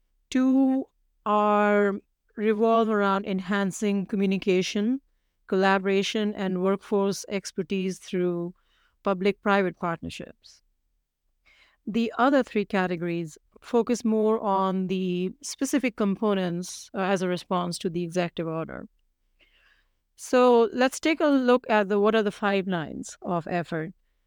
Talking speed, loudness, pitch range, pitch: 110 wpm, -25 LUFS, 185-225 Hz, 200 Hz